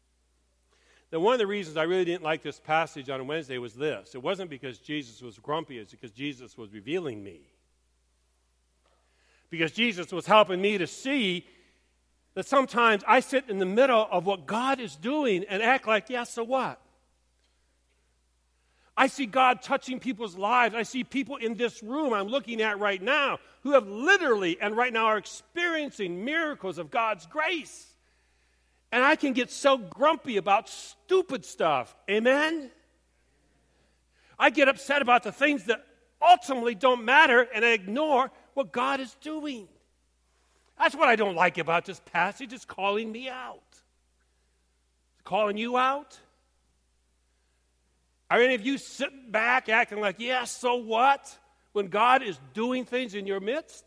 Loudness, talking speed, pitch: -26 LUFS, 160 wpm, 215 Hz